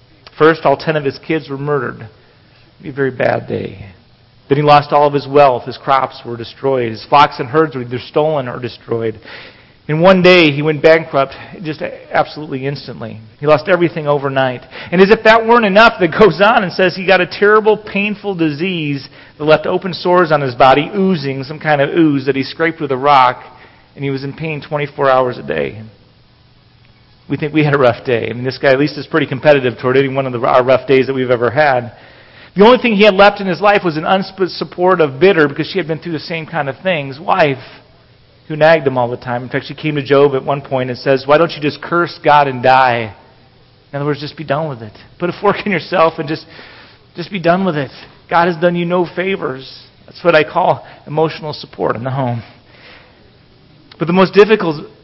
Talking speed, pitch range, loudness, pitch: 225 wpm, 130-170 Hz, -13 LUFS, 145 Hz